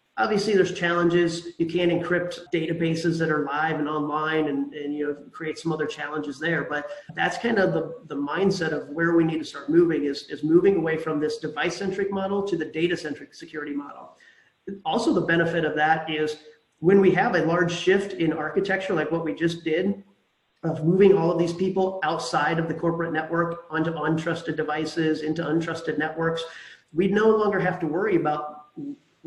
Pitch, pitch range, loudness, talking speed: 165 Hz, 155-175 Hz, -24 LUFS, 190 wpm